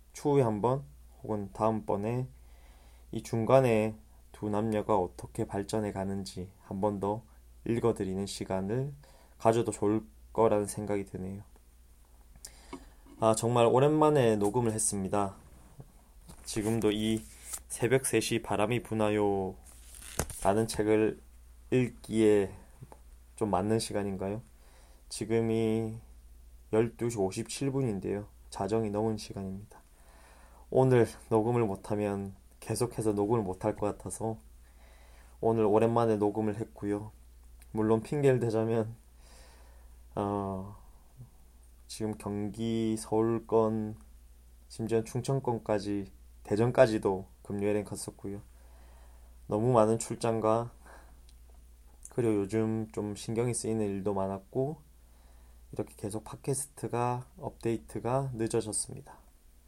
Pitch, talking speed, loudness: 105 Hz, 230 characters per minute, -31 LUFS